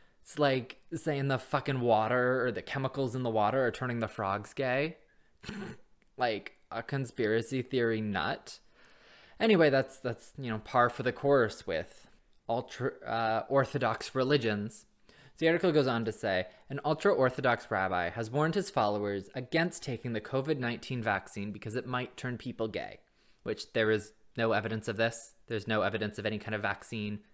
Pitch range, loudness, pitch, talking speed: 110-135 Hz, -32 LUFS, 120 Hz, 170 wpm